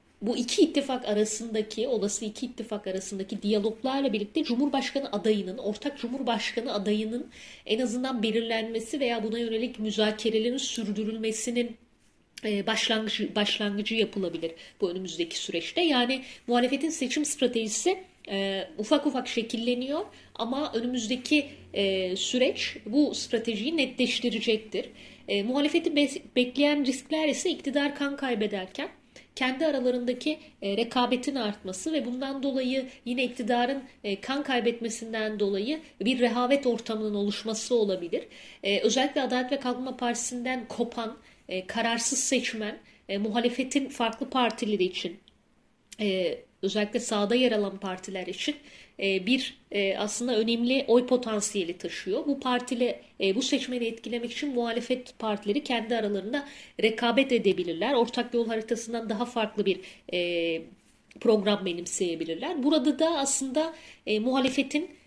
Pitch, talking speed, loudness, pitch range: 235 Hz, 105 wpm, -28 LUFS, 215-265 Hz